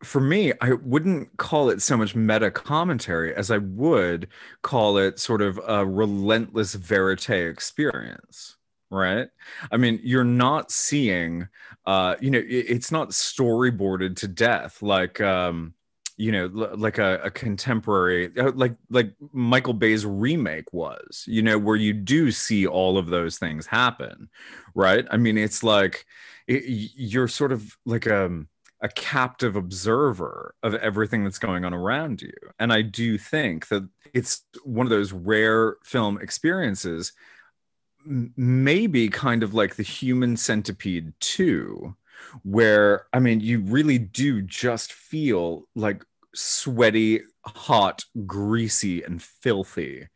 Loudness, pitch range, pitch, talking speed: -23 LUFS, 95-125 Hz, 110 Hz, 140 wpm